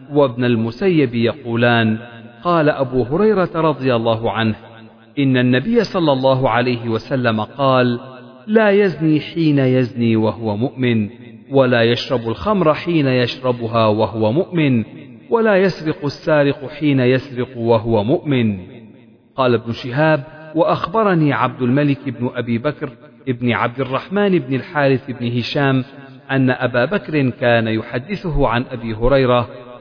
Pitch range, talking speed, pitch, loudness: 120-150 Hz, 120 wpm, 130 Hz, -17 LUFS